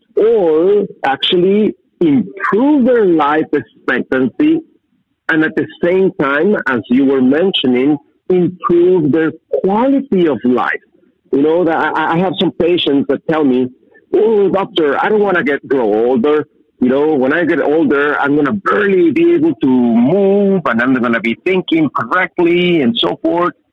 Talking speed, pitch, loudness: 155 wpm, 185 Hz, -13 LUFS